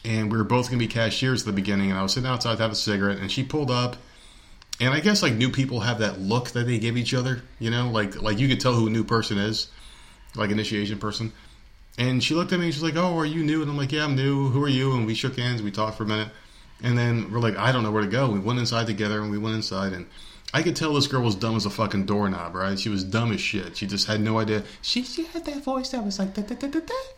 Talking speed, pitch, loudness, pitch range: 305 wpm, 115 Hz, -25 LUFS, 105-135 Hz